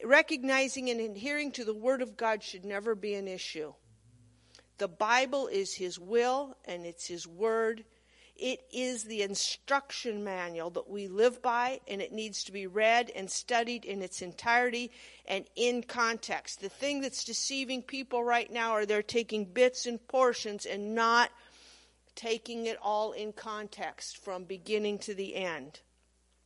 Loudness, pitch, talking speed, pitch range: -32 LUFS, 225 Hz, 160 wpm, 195-245 Hz